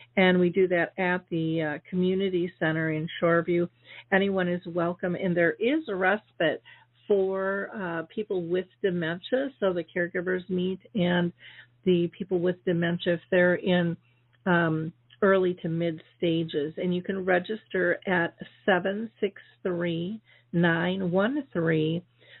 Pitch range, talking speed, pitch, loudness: 170-190 Hz, 125 wpm, 180 Hz, -27 LUFS